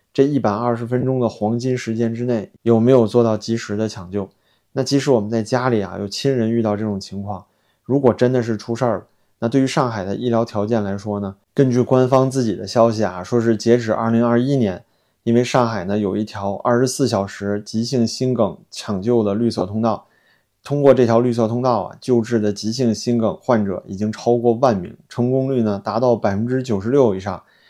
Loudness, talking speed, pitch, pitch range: -19 LUFS, 315 characters per minute, 115 Hz, 105-125 Hz